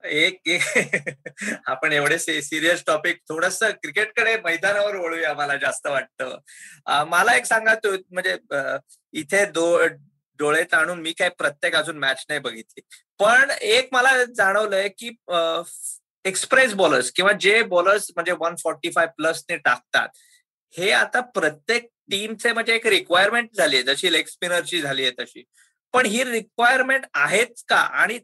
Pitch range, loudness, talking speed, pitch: 165-230 Hz, -20 LUFS, 135 wpm, 185 Hz